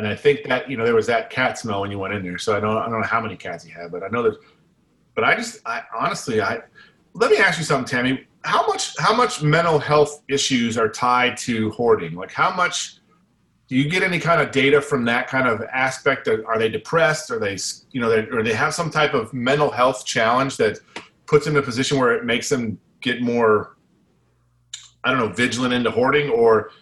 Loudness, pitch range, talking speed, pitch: -20 LUFS, 115-155 Hz, 235 wpm, 130 Hz